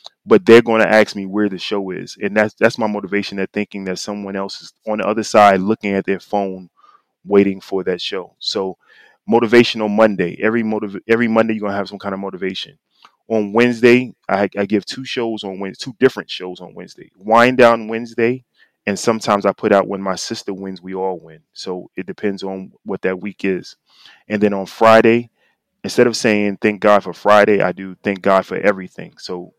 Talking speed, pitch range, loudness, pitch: 210 wpm, 95-110 Hz, -16 LUFS, 105 Hz